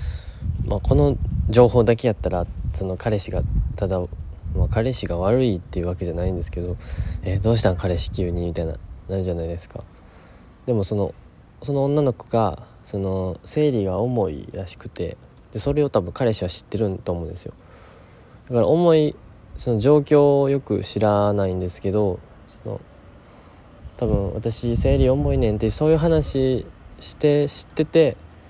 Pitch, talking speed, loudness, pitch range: 100 Hz, 315 characters per minute, -22 LUFS, 90-120 Hz